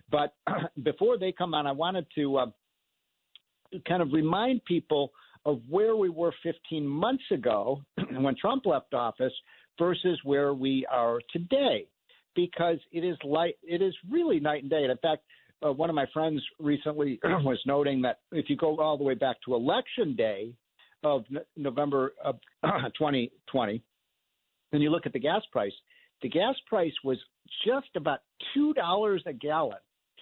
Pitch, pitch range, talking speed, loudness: 155 Hz, 140-180 Hz, 165 wpm, -29 LUFS